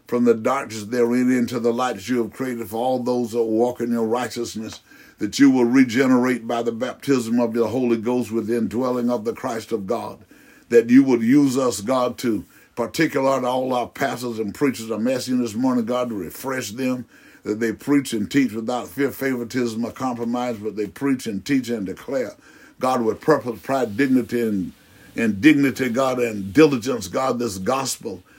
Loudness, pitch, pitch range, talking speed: -21 LUFS, 125 Hz, 115-135 Hz, 190 wpm